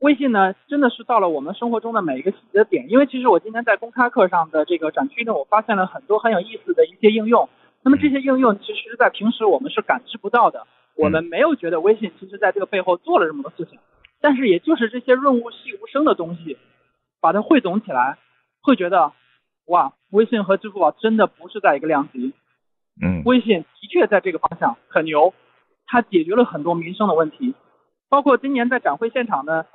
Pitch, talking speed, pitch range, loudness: 235 Hz, 335 characters per minute, 200-275 Hz, -19 LUFS